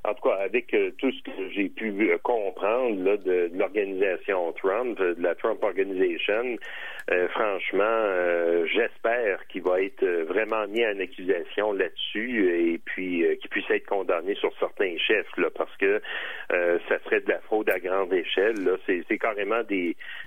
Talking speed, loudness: 170 wpm, -26 LUFS